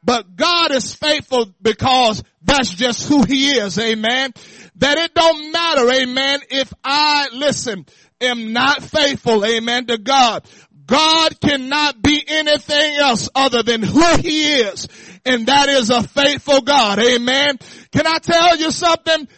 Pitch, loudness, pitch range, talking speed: 270 Hz, -15 LUFS, 240-295 Hz, 145 wpm